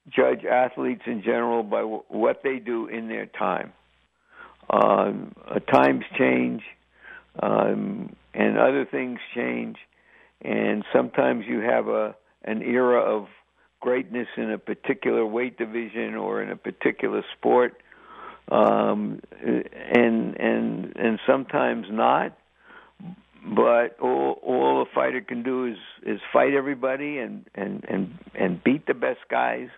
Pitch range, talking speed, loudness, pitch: 110-125 Hz, 130 wpm, -24 LUFS, 120 Hz